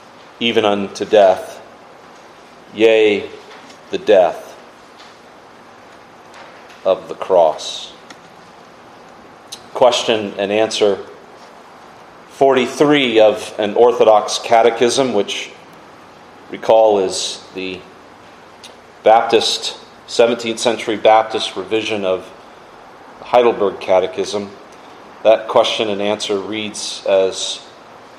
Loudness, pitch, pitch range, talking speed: -15 LUFS, 110 Hz, 100-115 Hz, 75 wpm